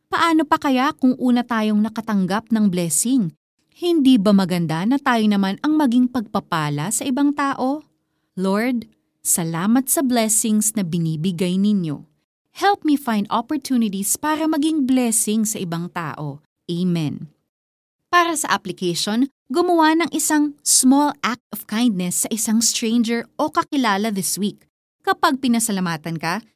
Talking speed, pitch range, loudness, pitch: 135 wpm, 195-275 Hz, -19 LUFS, 225 Hz